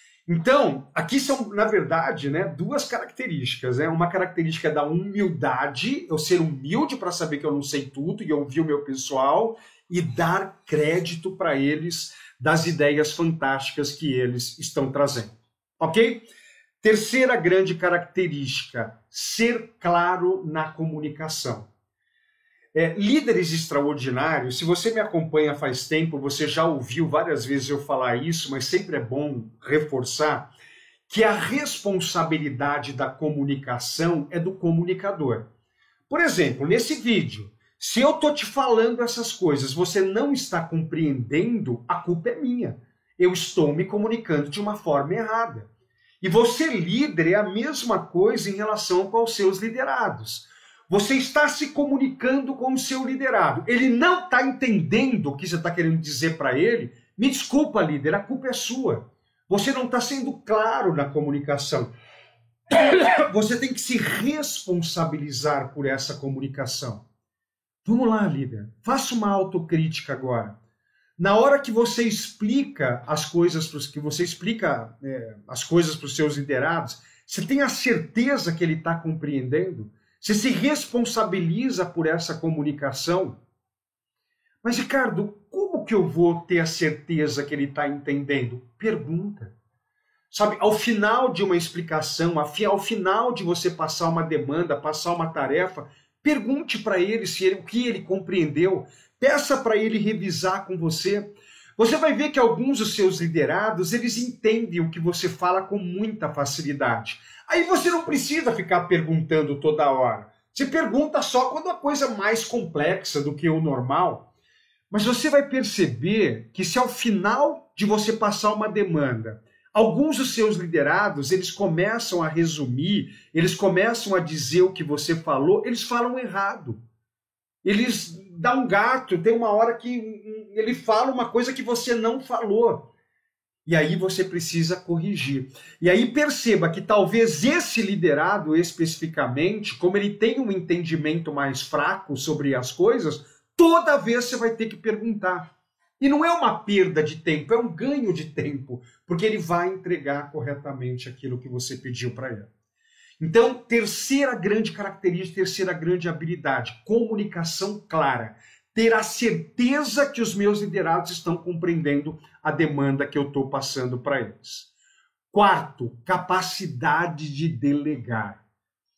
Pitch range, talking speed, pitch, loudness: 150-225 Hz, 145 wpm, 180 Hz, -23 LUFS